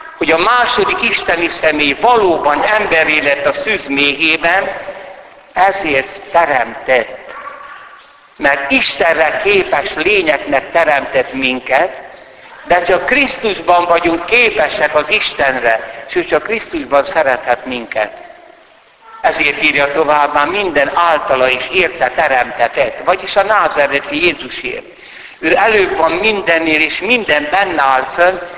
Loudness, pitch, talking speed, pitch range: -12 LUFS, 175 Hz, 110 wpm, 145-240 Hz